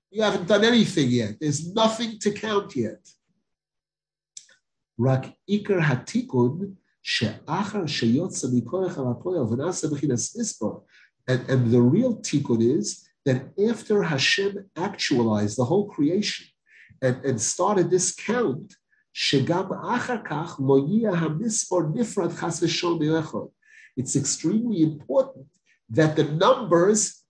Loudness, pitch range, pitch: -24 LUFS, 135-210 Hz, 175 Hz